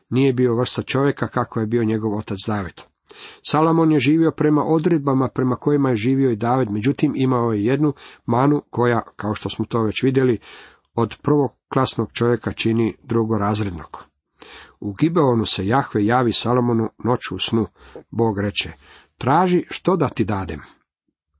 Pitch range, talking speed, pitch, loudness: 110-140 Hz, 155 wpm, 120 Hz, -20 LUFS